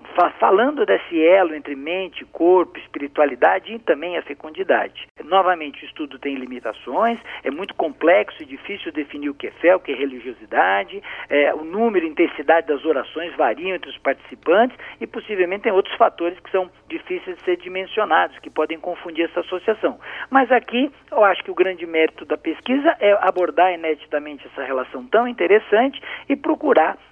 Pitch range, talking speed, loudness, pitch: 155-230 Hz, 170 wpm, -20 LUFS, 180 Hz